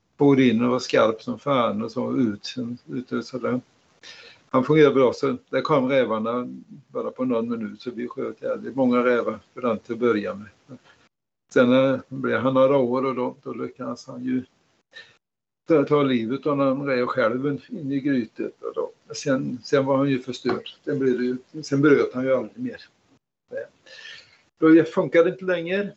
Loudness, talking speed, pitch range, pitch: -23 LUFS, 175 wpm, 125-155 Hz, 130 Hz